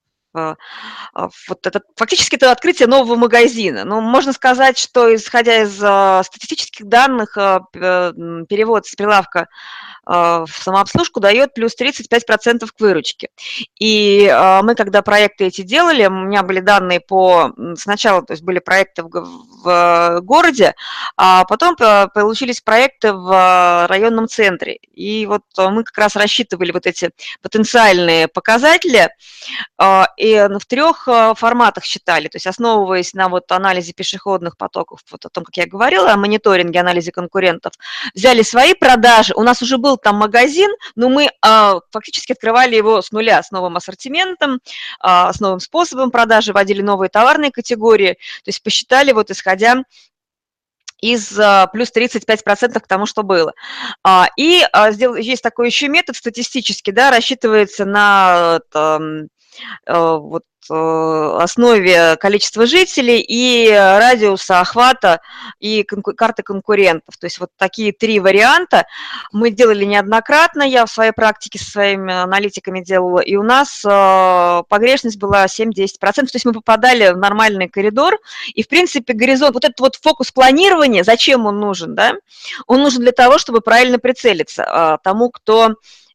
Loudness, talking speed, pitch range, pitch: -12 LUFS, 135 wpm, 190-245 Hz, 215 Hz